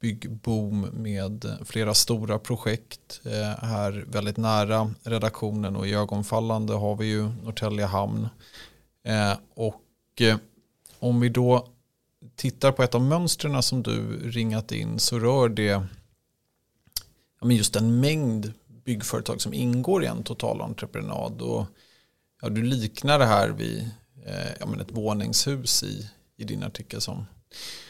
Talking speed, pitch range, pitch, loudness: 115 wpm, 105-120 Hz, 110 Hz, -26 LUFS